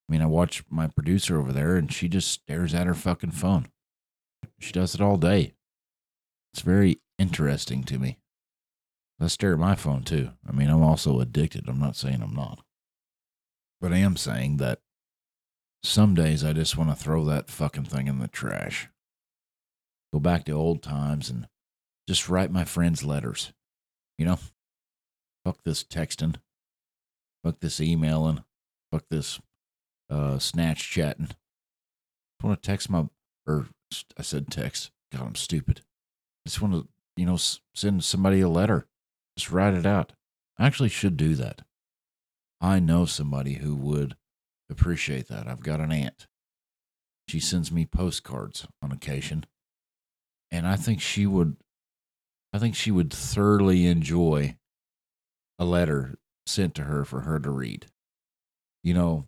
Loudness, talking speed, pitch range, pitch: -26 LUFS, 155 wpm, 70-90 Hz, 80 Hz